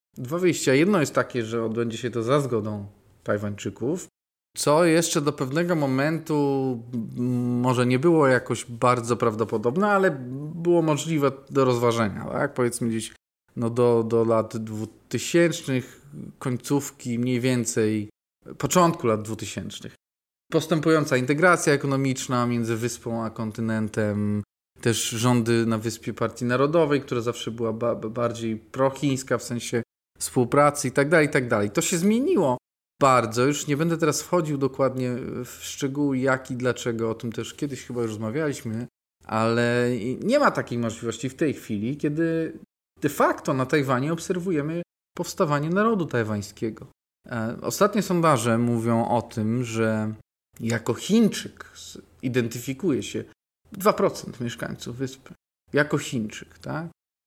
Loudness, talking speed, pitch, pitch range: -24 LUFS, 130 wpm, 125 Hz, 115-150 Hz